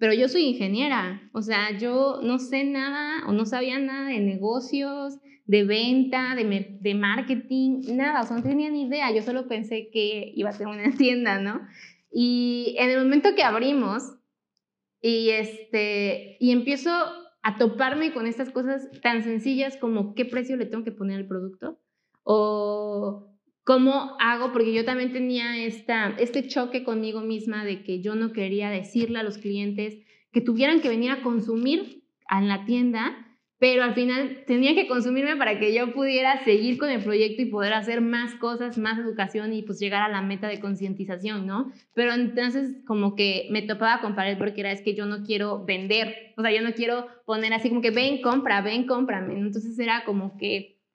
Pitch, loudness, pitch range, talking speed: 235 Hz, -25 LUFS, 210-255 Hz, 185 wpm